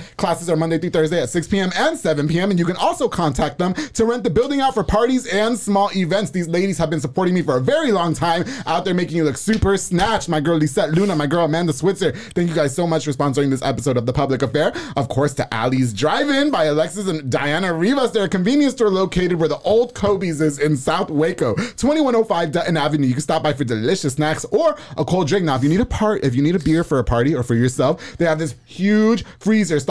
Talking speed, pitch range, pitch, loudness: 255 wpm, 150-200 Hz, 170 Hz, -19 LUFS